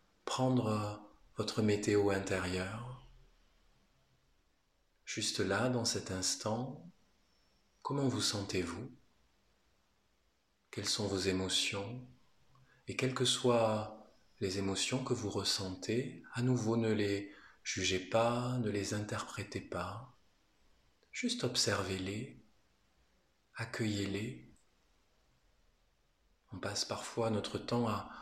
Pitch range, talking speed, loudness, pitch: 95-120 Hz, 95 wpm, -36 LUFS, 100 Hz